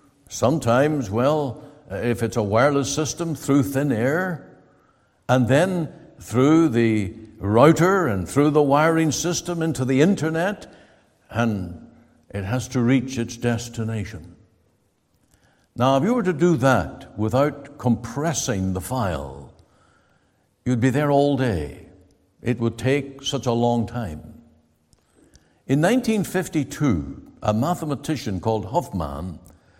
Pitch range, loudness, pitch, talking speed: 110-150 Hz, -22 LUFS, 130 Hz, 120 wpm